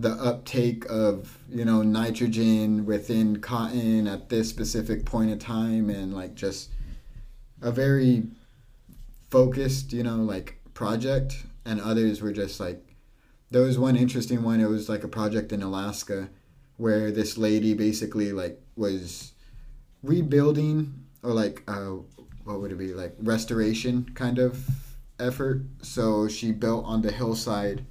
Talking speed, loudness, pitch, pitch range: 140 wpm, -26 LUFS, 115 Hz, 105-125 Hz